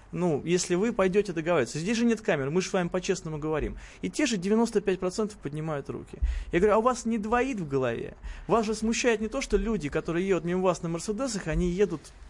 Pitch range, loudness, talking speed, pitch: 165-220 Hz, -28 LUFS, 220 wpm, 185 Hz